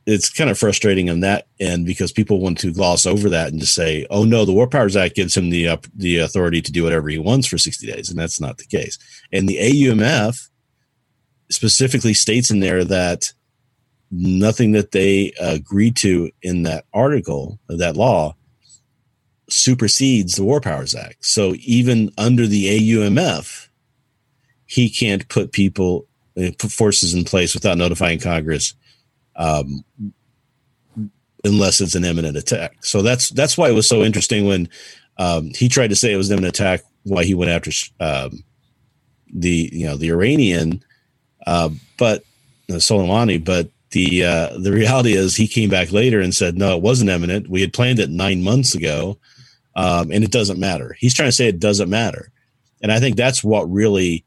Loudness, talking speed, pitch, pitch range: -17 LUFS, 180 wpm, 100 Hz, 90-120 Hz